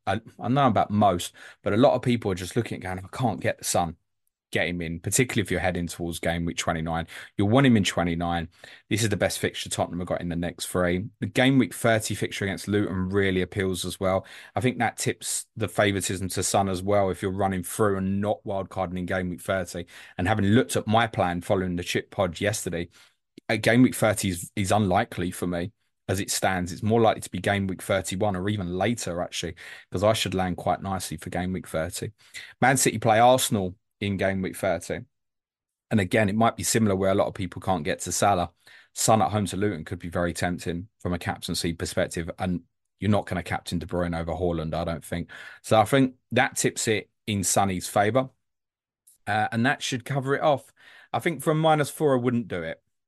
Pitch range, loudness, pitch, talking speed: 90-110 Hz, -26 LUFS, 95 Hz, 225 wpm